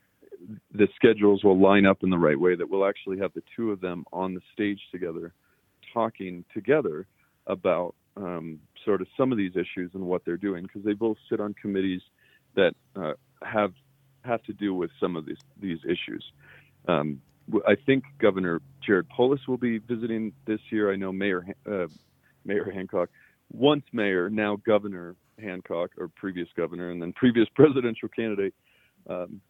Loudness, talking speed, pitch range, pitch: -27 LUFS, 170 wpm, 90-115 Hz, 100 Hz